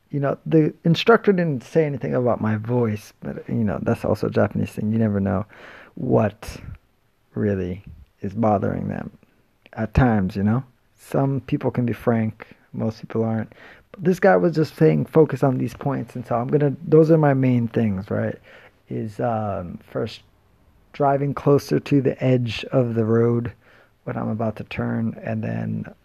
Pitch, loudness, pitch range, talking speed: 120 Hz, -22 LUFS, 110-140 Hz, 175 wpm